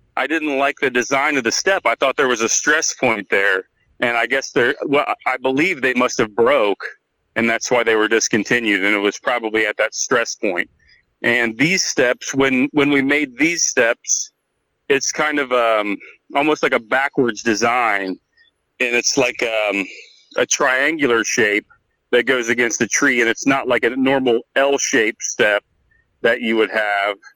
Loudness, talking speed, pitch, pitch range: -17 LUFS, 185 wpm, 130 Hz, 115-140 Hz